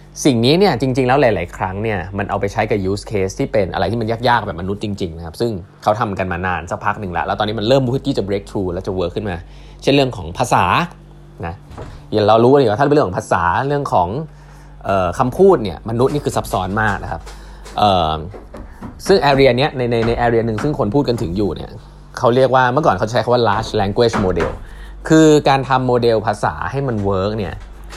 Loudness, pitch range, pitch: -16 LUFS, 100-135 Hz, 115 Hz